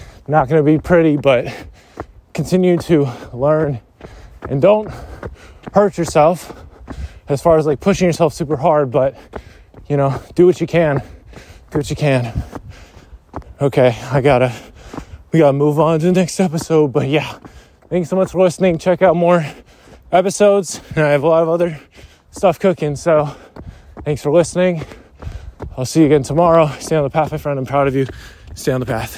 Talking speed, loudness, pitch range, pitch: 180 wpm, -15 LUFS, 130-170 Hz, 150 Hz